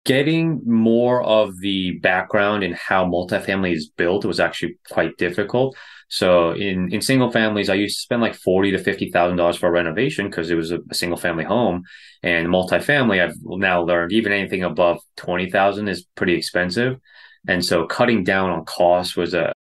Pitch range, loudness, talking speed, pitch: 90-110 Hz, -19 LUFS, 185 wpm, 95 Hz